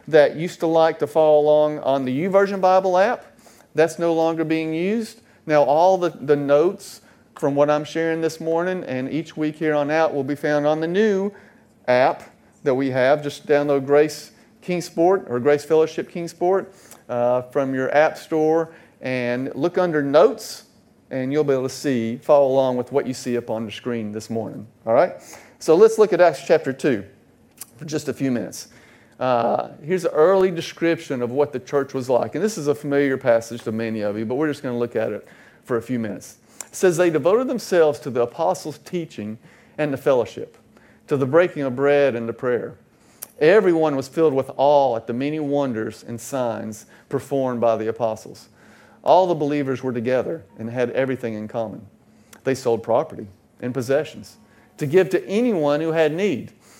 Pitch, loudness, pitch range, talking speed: 145 Hz, -21 LUFS, 130-165 Hz, 190 wpm